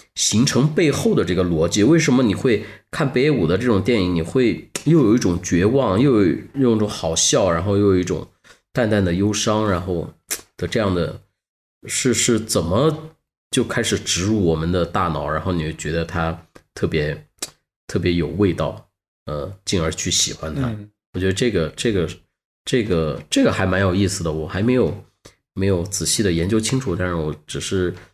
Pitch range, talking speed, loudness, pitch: 85-110 Hz, 265 characters per minute, -19 LUFS, 95 Hz